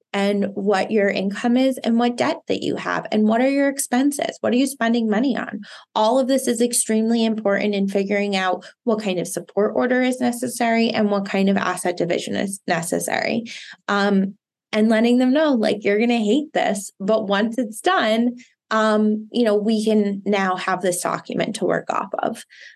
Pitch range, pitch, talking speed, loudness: 200-240 Hz, 220 Hz, 195 wpm, -20 LUFS